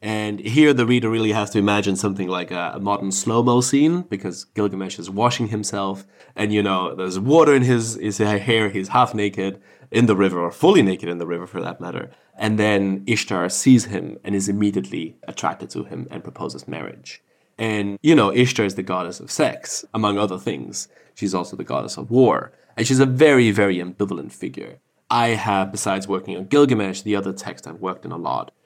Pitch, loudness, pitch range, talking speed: 105 Hz, -20 LUFS, 95-115 Hz, 205 wpm